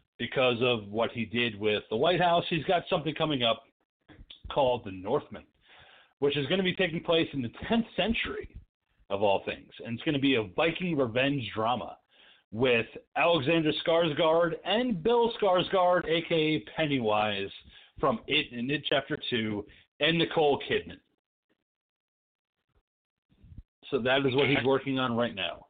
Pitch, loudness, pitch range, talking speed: 150 Hz, -28 LUFS, 125-170 Hz, 155 wpm